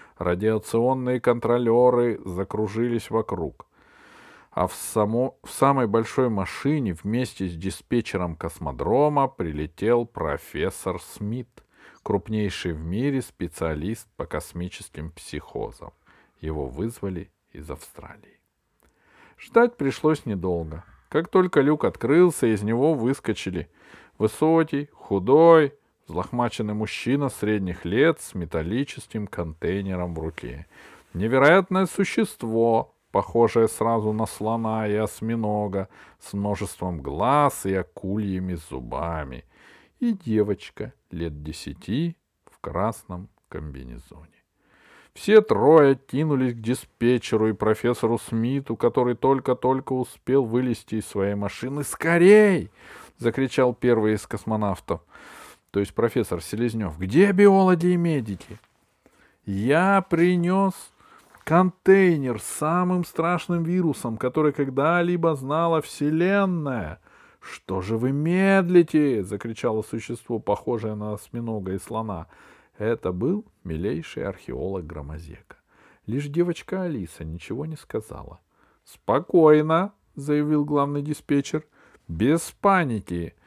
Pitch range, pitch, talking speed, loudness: 100-145 Hz, 115 Hz, 100 wpm, -23 LUFS